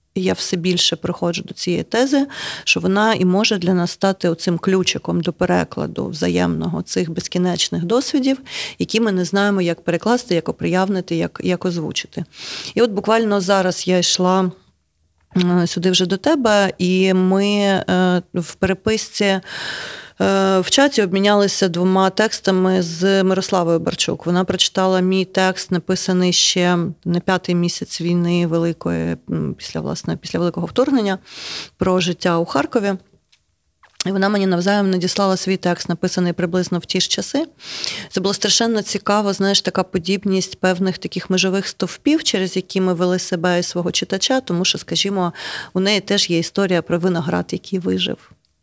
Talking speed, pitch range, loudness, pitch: 145 wpm, 175-200 Hz, -18 LUFS, 185 Hz